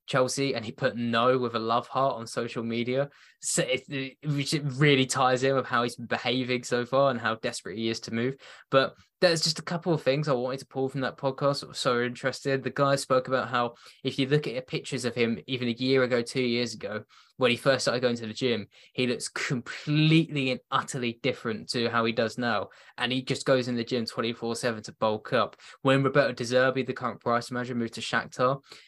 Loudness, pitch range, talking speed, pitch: -28 LUFS, 120-135 Hz, 230 wpm, 130 Hz